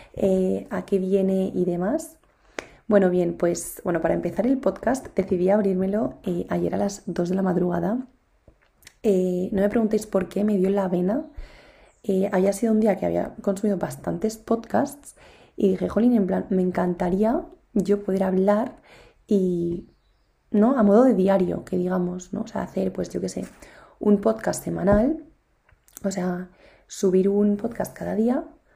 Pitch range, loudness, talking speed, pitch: 185-220 Hz, -23 LUFS, 165 wpm, 200 Hz